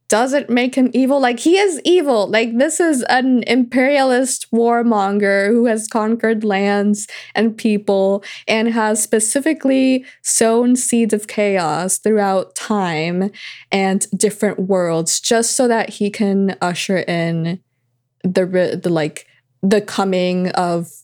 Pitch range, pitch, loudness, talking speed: 190-245 Hz, 215 Hz, -16 LUFS, 130 wpm